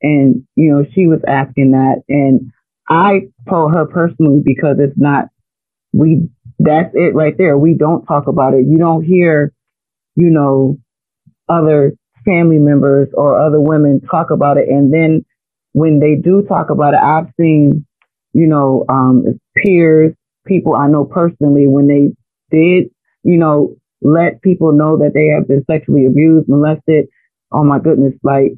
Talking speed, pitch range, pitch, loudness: 160 wpm, 140-160 Hz, 150 Hz, -11 LUFS